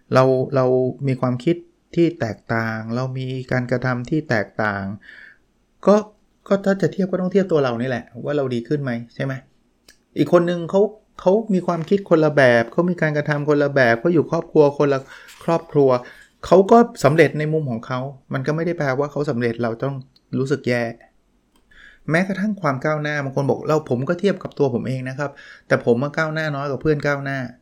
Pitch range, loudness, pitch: 130-165 Hz, -20 LUFS, 145 Hz